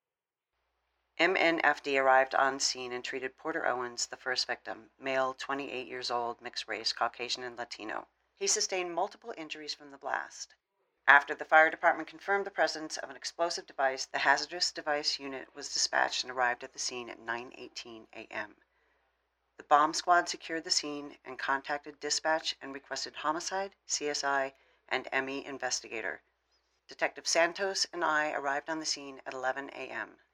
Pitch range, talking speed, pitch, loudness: 130-160 Hz, 155 wpm, 140 Hz, -31 LUFS